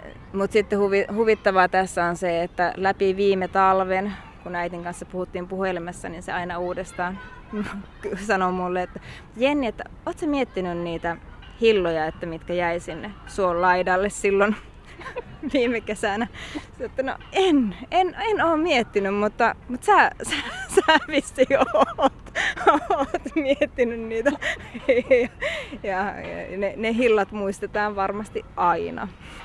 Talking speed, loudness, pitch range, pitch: 130 wpm, -23 LUFS, 185-270 Hz, 205 Hz